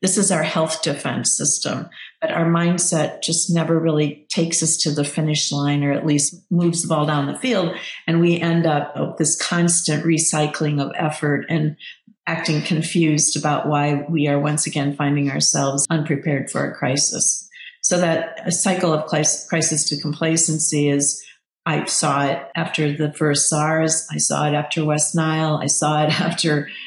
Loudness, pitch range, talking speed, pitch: -19 LUFS, 150-165 Hz, 170 wpm, 155 Hz